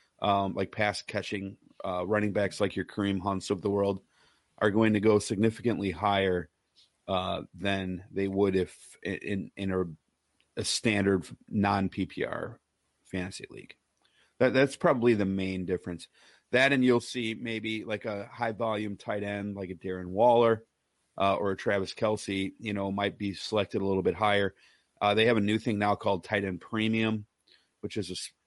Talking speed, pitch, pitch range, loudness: 175 wpm, 100 Hz, 95-110 Hz, -29 LUFS